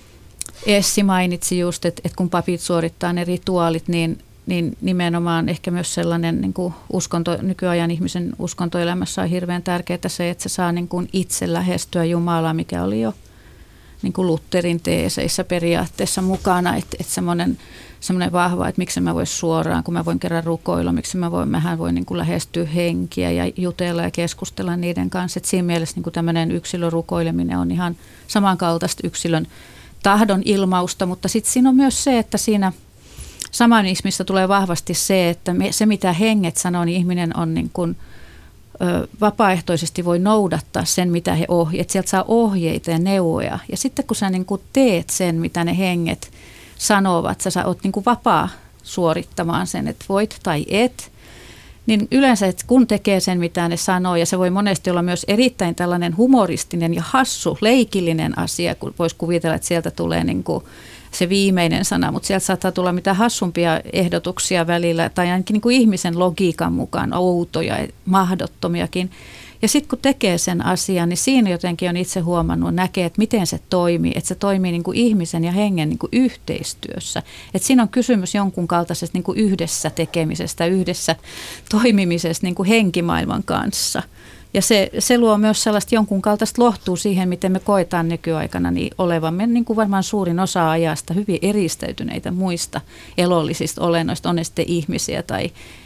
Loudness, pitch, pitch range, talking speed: -19 LUFS, 180 Hz, 170-195 Hz, 170 wpm